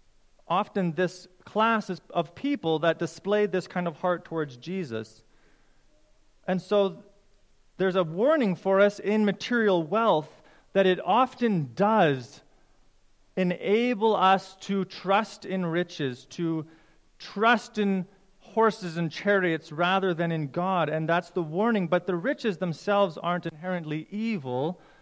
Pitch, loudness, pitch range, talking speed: 185 Hz, -27 LUFS, 170-205 Hz, 130 wpm